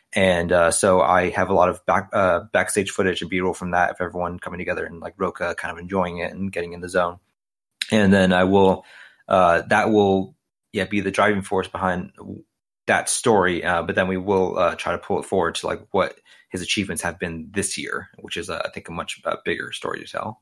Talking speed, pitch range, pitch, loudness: 230 wpm, 90-95 Hz, 95 Hz, -21 LUFS